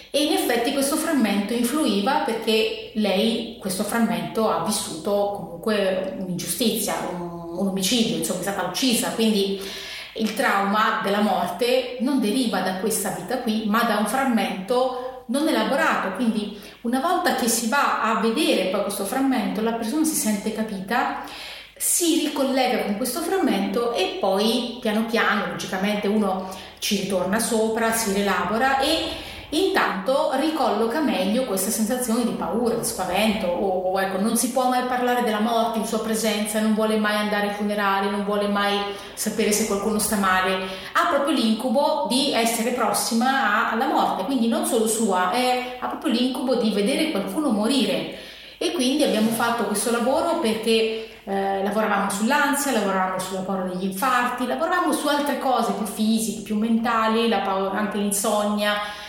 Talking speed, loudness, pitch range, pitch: 155 wpm, -22 LUFS, 200-250 Hz, 220 Hz